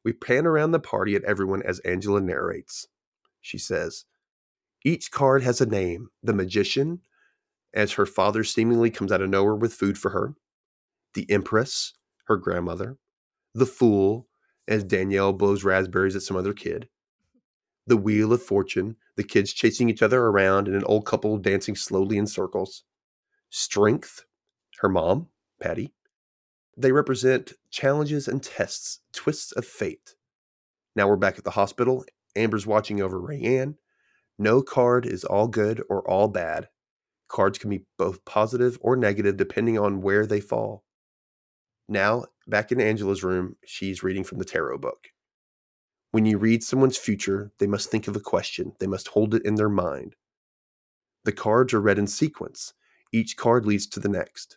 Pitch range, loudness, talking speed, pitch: 100-125 Hz, -24 LUFS, 160 wpm, 105 Hz